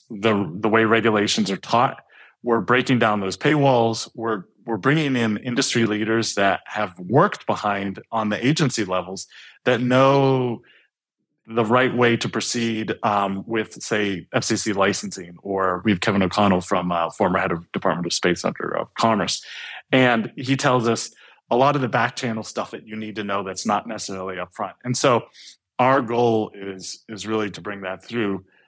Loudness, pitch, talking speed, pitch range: -21 LUFS, 110 Hz, 175 wpm, 100-120 Hz